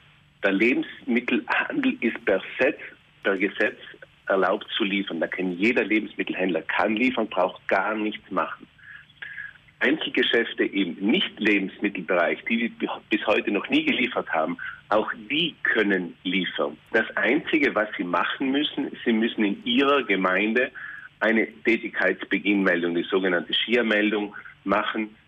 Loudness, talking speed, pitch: -24 LUFS, 125 wpm, 110 Hz